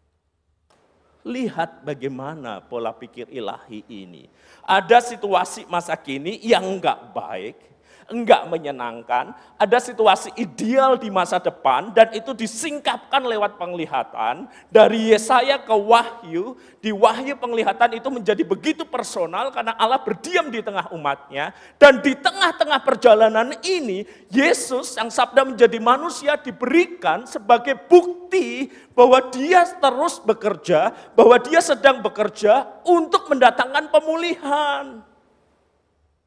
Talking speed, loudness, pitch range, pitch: 110 wpm, -19 LUFS, 180-275 Hz, 235 Hz